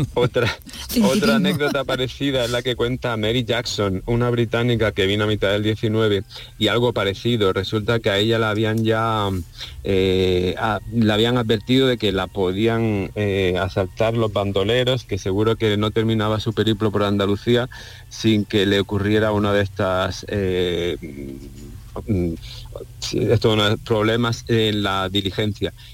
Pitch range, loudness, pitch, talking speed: 100-115 Hz, -20 LUFS, 110 Hz, 140 wpm